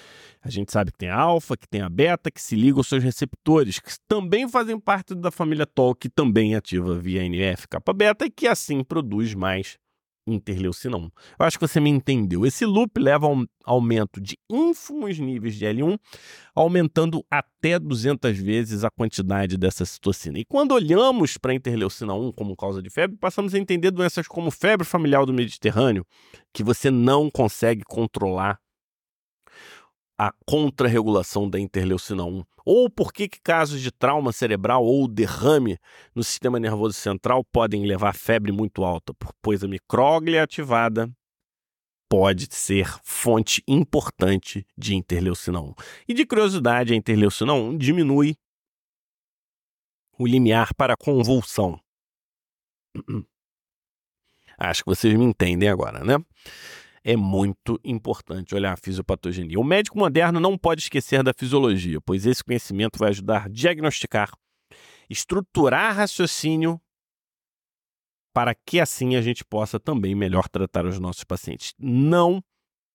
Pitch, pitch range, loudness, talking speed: 120 Hz, 100-155 Hz, -22 LUFS, 145 wpm